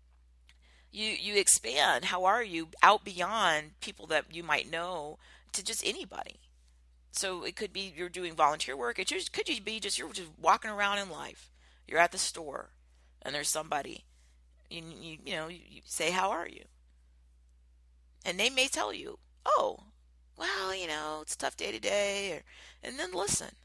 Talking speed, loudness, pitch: 180 wpm, -31 LUFS, 155 Hz